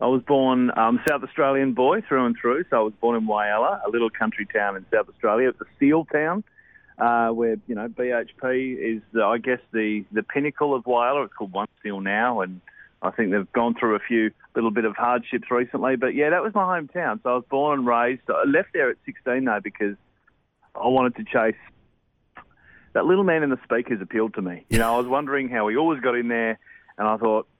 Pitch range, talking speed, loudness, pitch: 110-135 Hz, 230 wpm, -23 LUFS, 120 Hz